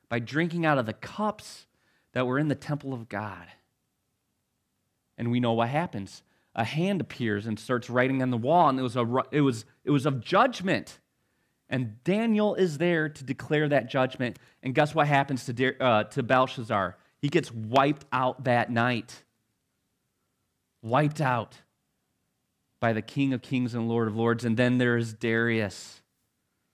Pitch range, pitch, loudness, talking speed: 115-140 Hz, 125 Hz, -27 LUFS, 170 wpm